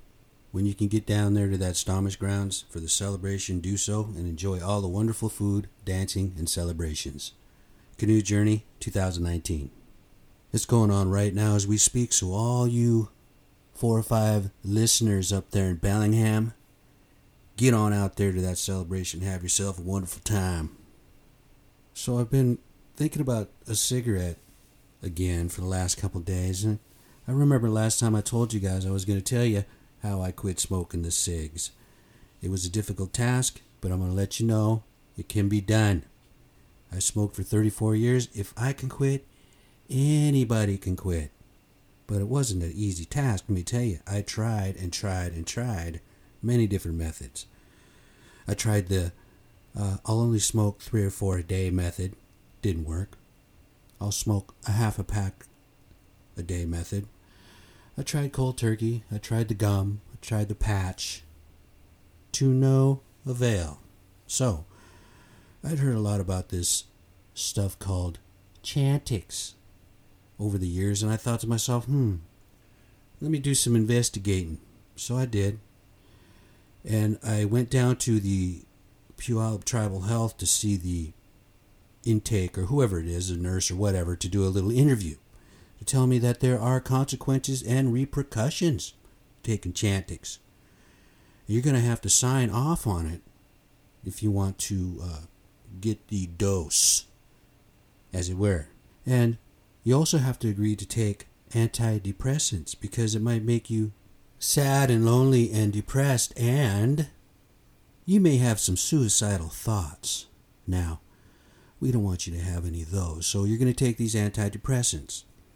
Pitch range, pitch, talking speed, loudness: 95-115 Hz, 105 Hz, 155 wpm, -27 LUFS